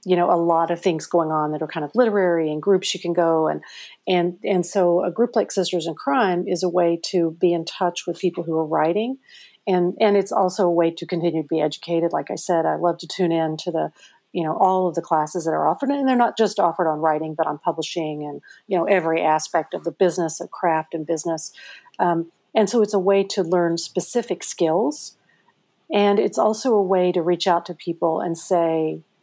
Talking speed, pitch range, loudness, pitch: 235 wpm, 165-190 Hz, -21 LUFS, 175 Hz